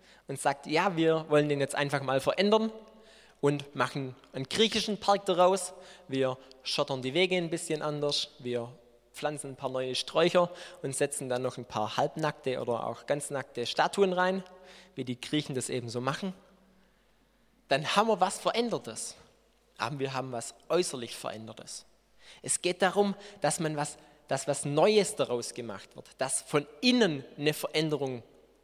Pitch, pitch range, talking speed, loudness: 150 Hz, 135-185 Hz, 160 wpm, -30 LUFS